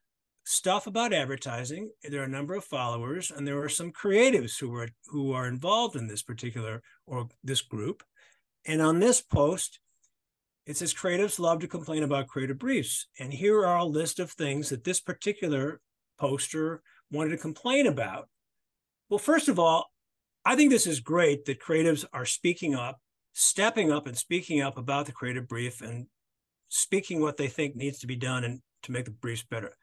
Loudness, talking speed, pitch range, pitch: -28 LUFS, 185 wpm, 130-175 Hz, 145 Hz